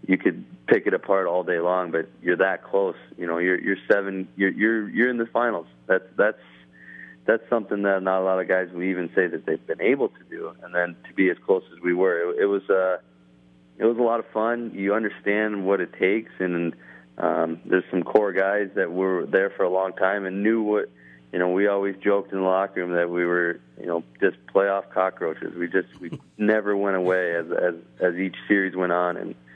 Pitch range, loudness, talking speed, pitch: 90-105 Hz, -24 LUFS, 230 wpm, 95 Hz